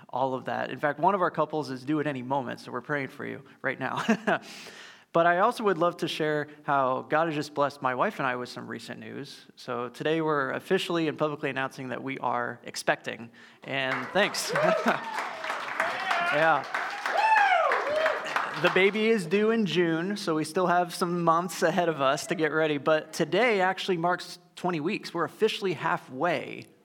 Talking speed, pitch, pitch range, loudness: 185 wpm, 160 Hz, 145-180 Hz, -27 LUFS